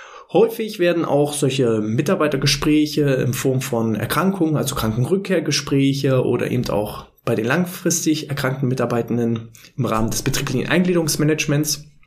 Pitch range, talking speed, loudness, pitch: 125-155 Hz, 120 wpm, -19 LUFS, 140 Hz